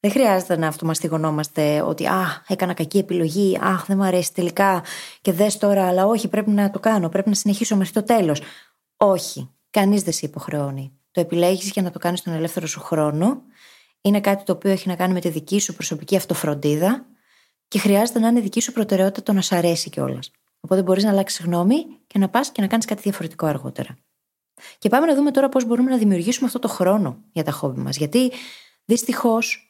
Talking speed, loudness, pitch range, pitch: 205 wpm, -20 LUFS, 170-215 Hz, 195 Hz